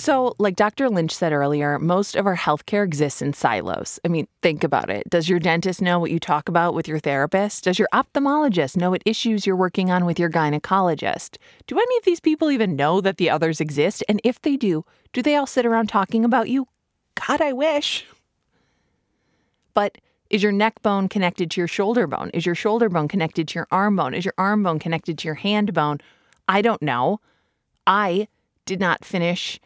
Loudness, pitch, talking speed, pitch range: -21 LUFS, 190 Hz, 205 wpm, 165-220 Hz